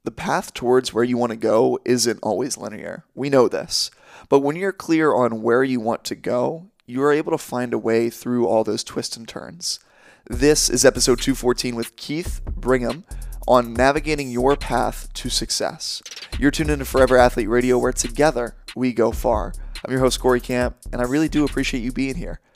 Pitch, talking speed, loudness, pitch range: 125 Hz, 195 wpm, -20 LUFS, 120-135 Hz